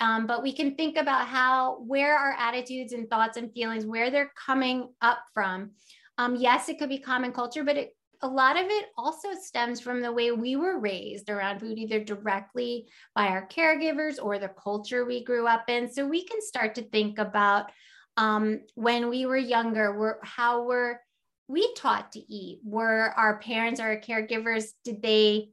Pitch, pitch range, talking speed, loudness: 240 Hz, 220-260 Hz, 190 wpm, -27 LUFS